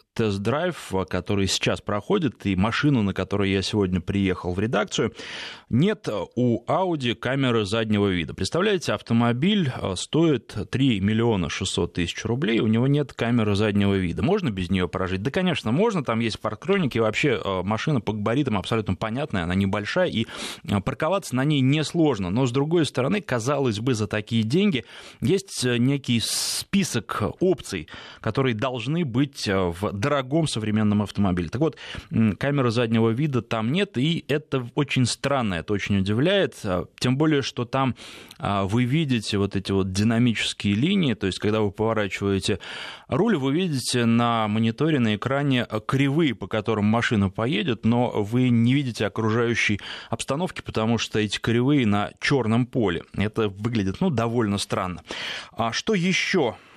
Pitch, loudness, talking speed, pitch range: 115 Hz, -24 LUFS, 145 wpm, 105-135 Hz